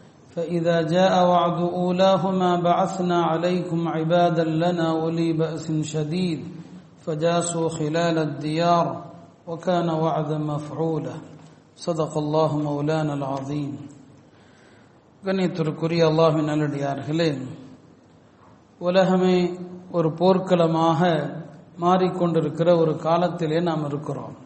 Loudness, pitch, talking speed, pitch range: -22 LUFS, 165 Hz, 90 wpm, 155-175 Hz